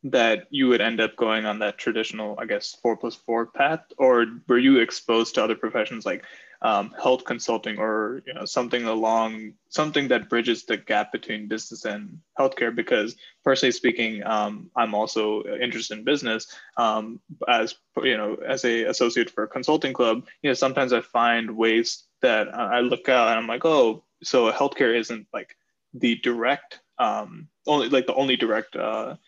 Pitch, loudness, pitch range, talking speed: 115 Hz, -24 LUFS, 110-125 Hz, 180 wpm